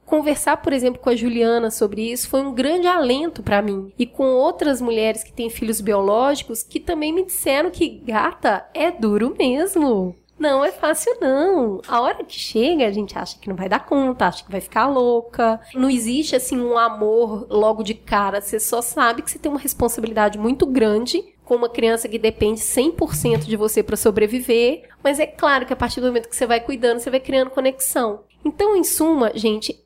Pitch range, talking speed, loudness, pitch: 225-290 Hz, 200 wpm, -19 LUFS, 245 Hz